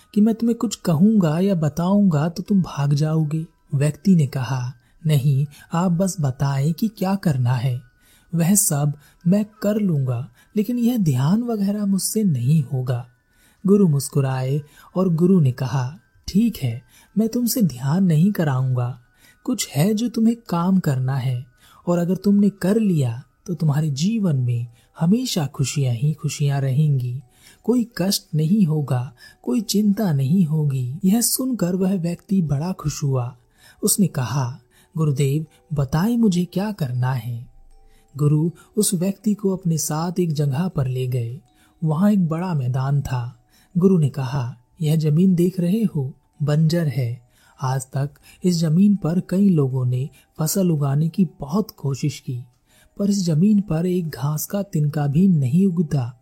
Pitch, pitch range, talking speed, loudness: 155 Hz, 135-190 Hz, 150 wpm, -21 LUFS